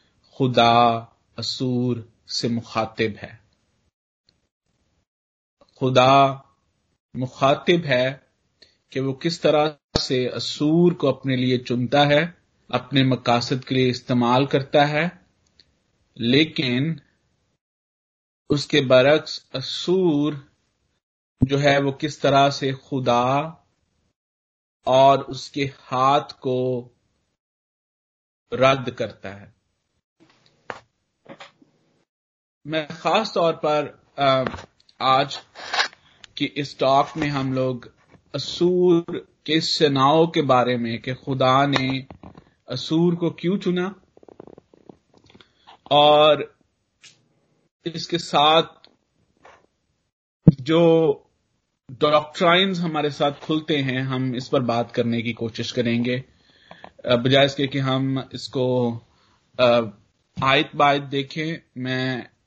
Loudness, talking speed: -21 LUFS, 90 wpm